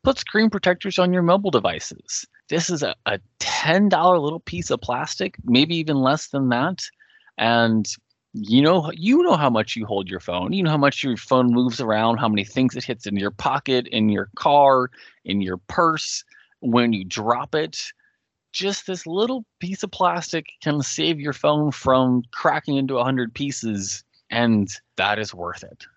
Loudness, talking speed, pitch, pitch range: -21 LUFS, 180 wpm, 135 Hz, 115-180 Hz